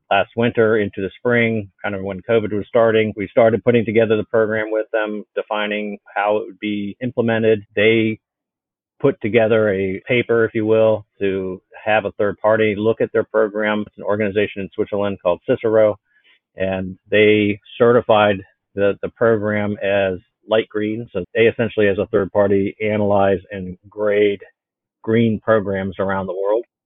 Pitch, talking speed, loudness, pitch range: 105 Hz, 165 wpm, -18 LUFS, 100-110 Hz